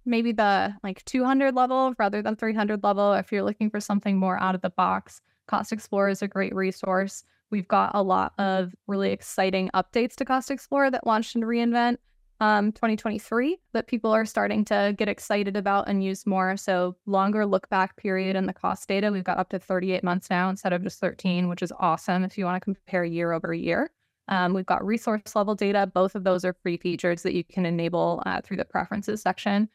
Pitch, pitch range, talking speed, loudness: 200 Hz, 185-215 Hz, 210 wpm, -26 LUFS